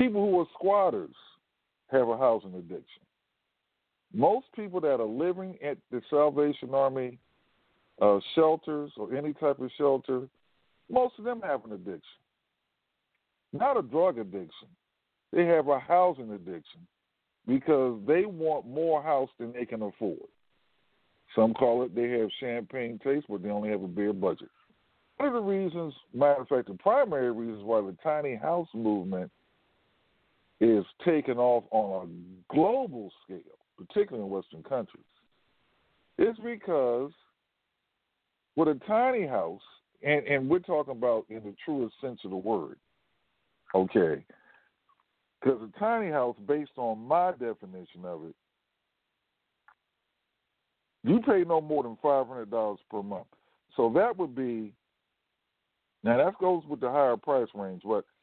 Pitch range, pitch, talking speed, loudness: 110-165 Hz, 135 Hz, 145 wpm, -29 LUFS